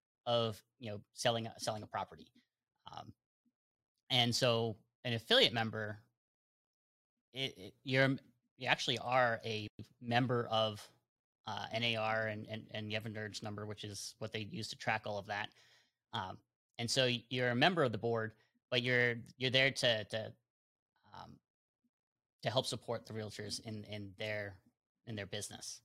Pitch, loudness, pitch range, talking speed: 115 Hz, -36 LUFS, 110-125 Hz, 165 wpm